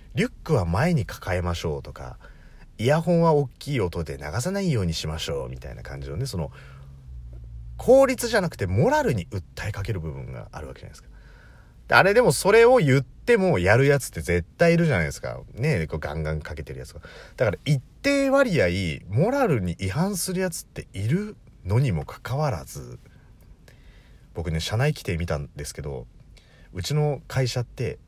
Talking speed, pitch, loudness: 355 characters per minute, 110 Hz, -23 LUFS